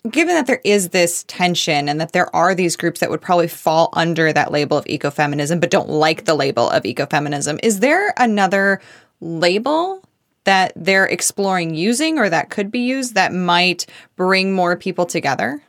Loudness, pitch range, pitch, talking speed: -17 LUFS, 160-200 Hz, 180 Hz, 180 wpm